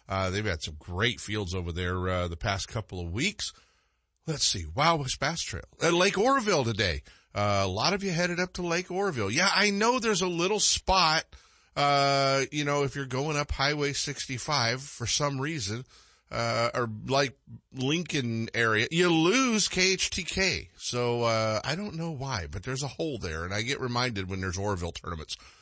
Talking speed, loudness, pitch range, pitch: 185 wpm, -28 LUFS, 105-165 Hz, 135 Hz